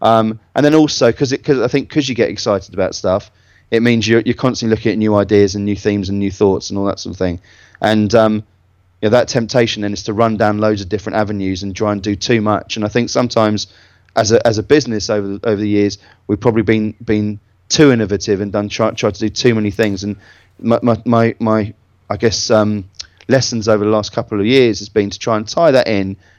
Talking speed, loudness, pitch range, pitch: 240 wpm, -15 LUFS, 100-115 Hz, 105 Hz